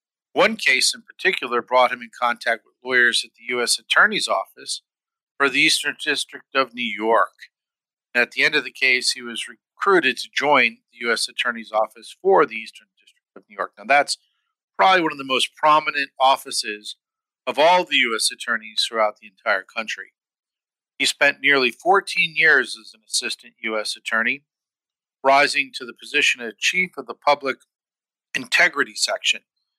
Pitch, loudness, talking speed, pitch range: 125 Hz, -20 LUFS, 170 wpm, 115-145 Hz